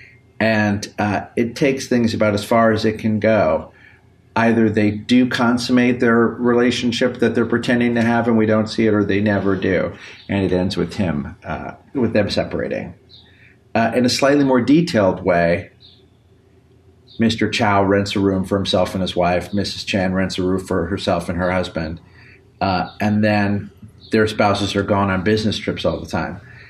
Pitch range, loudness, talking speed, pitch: 95-115 Hz, -18 LUFS, 180 wpm, 105 Hz